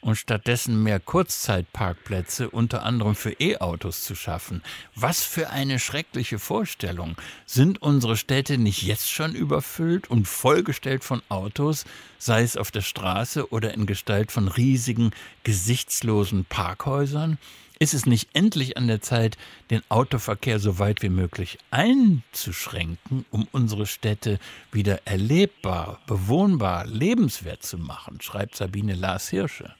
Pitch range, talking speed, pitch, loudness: 100-130 Hz, 130 wpm, 110 Hz, -24 LUFS